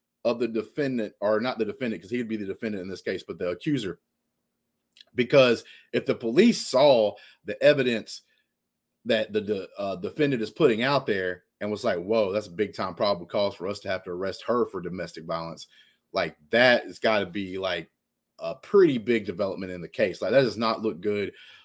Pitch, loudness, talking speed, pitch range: 110 Hz, -26 LUFS, 205 wpm, 95-120 Hz